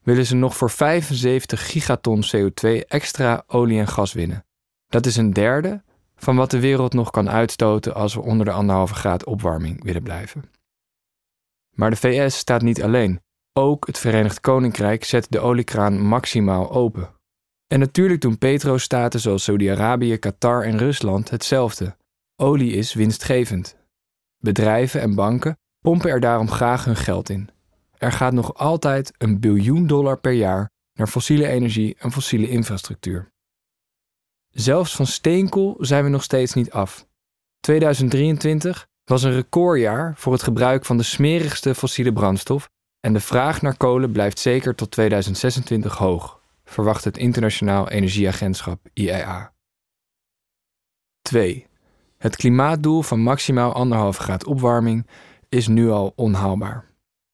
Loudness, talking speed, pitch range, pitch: -19 LUFS, 140 wpm, 105-130 Hz, 120 Hz